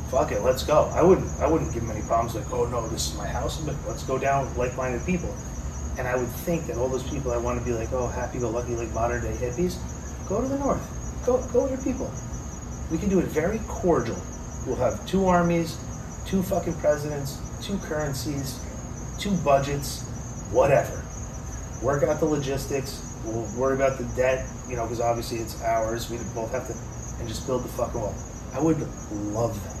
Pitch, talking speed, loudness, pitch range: 125 Hz, 205 wpm, -27 LUFS, 115-140 Hz